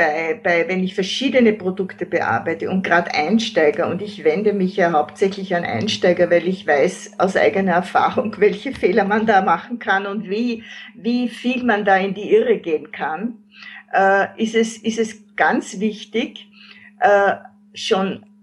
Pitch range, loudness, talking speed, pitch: 185-225 Hz, -19 LUFS, 165 wpm, 205 Hz